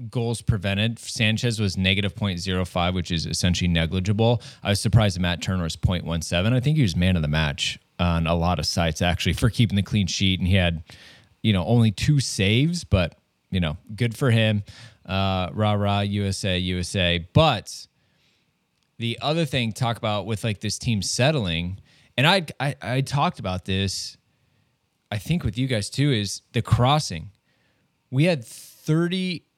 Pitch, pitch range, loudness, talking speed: 105 Hz, 90-125 Hz, -23 LUFS, 175 wpm